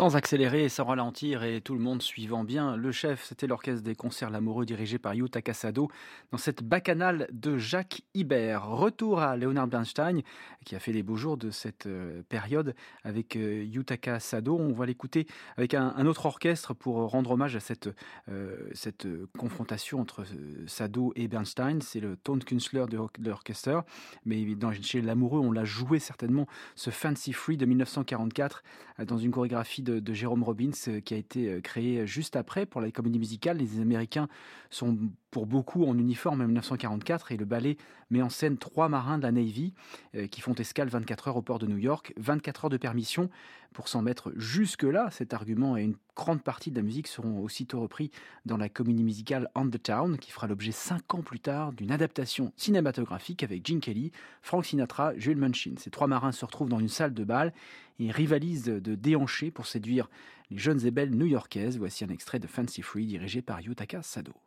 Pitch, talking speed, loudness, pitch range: 125 Hz, 195 wpm, -31 LUFS, 115-145 Hz